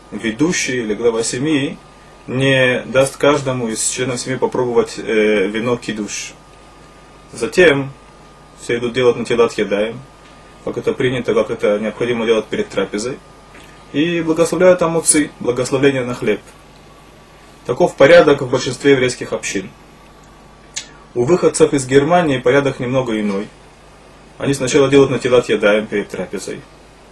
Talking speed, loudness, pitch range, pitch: 125 wpm, -16 LUFS, 115-140 Hz, 130 Hz